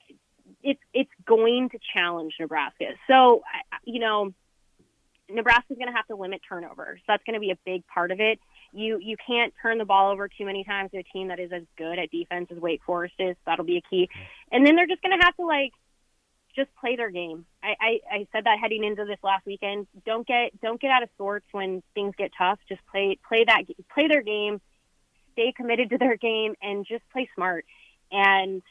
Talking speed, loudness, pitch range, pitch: 220 wpm, -25 LUFS, 185-235 Hz, 205 Hz